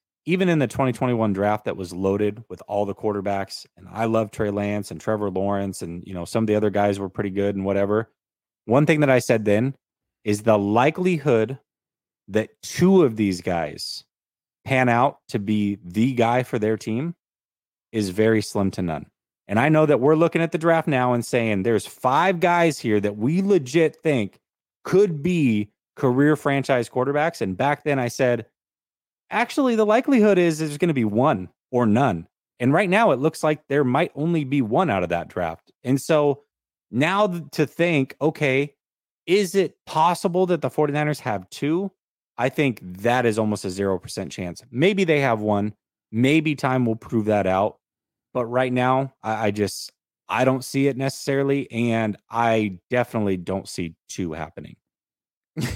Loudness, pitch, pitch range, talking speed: -22 LUFS, 120 Hz, 105-150 Hz, 180 wpm